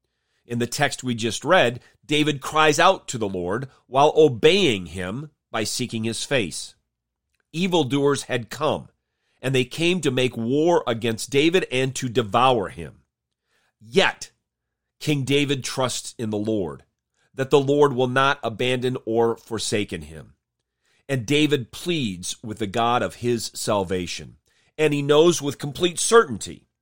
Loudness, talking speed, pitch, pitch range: -22 LUFS, 145 wpm, 125 Hz, 110-145 Hz